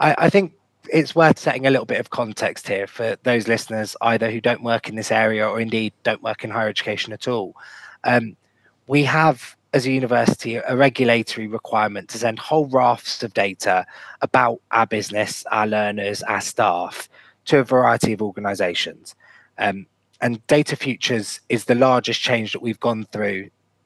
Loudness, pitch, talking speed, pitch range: -20 LUFS, 115 Hz, 175 wpm, 110-130 Hz